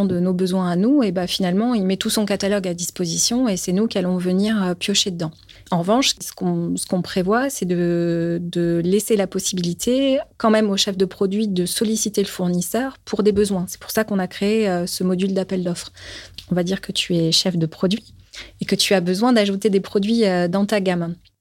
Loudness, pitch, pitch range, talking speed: -20 LUFS, 190 Hz, 180-210 Hz, 220 wpm